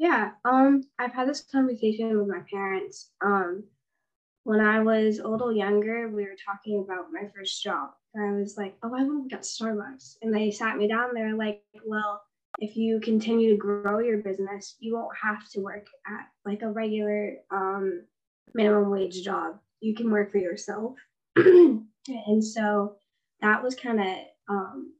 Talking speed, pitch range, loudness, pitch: 180 wpm, 200-230 Hz, -26 LUFS, 215 Hz